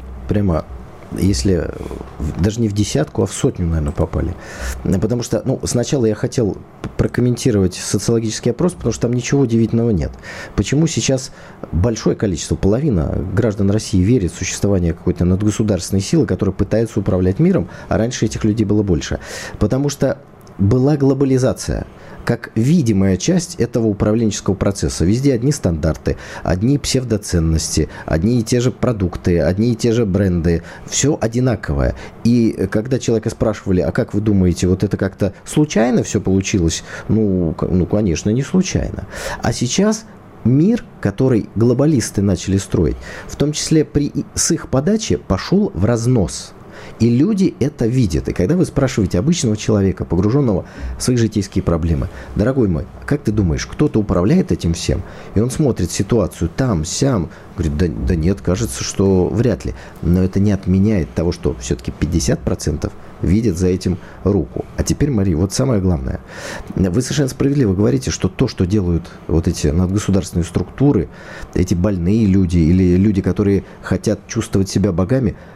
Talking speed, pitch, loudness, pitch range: 150 wpm, 105 Hz, -17 LUFS, 90-120 Hz